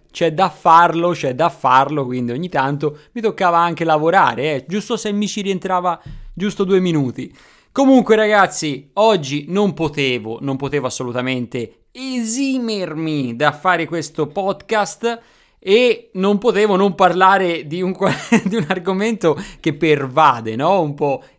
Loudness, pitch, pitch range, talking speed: -17 LUFS, 175 Hz, 145-205 Hz, 140 wpm